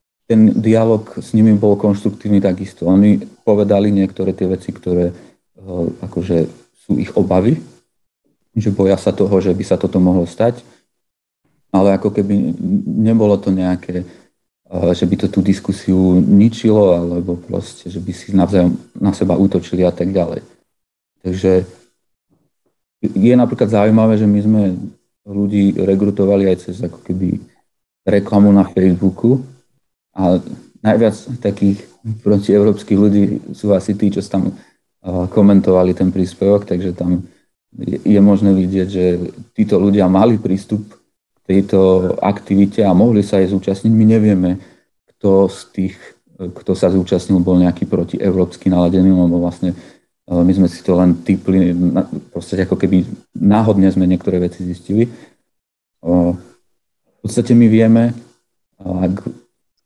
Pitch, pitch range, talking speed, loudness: 95 Hz, 90-105 Hz, 130 wpm, -14 LUFS